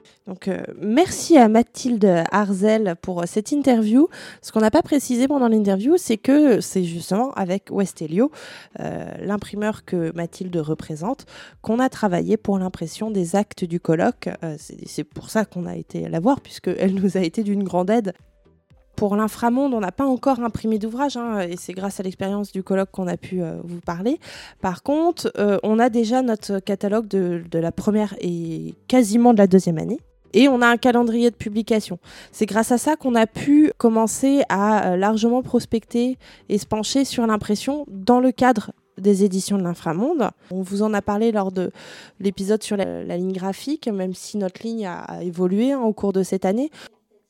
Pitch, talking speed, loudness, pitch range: 210 Hz, 190 wpm, -21 LUFS, 185-235 Hz